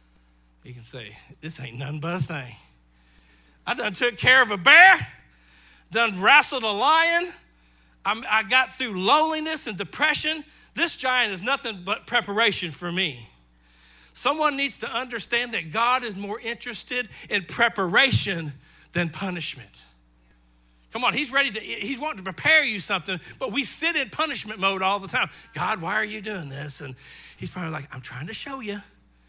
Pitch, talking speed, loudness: 200 Hz, 170 wpm, -22 LUFS